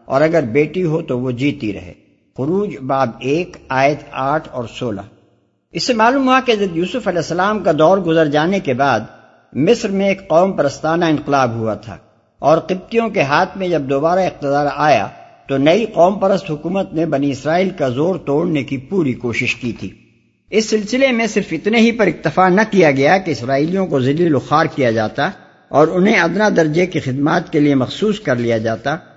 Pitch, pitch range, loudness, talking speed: 160 Hz, 140-185 Hz, -16 LUFS, 190 wpm